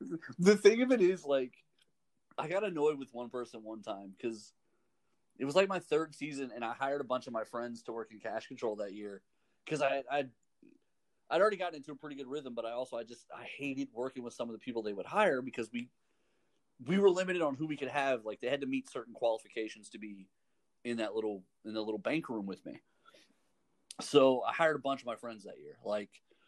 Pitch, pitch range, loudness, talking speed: 125 Hz, 110-145 Hz, -34 LUFS, 235 wpm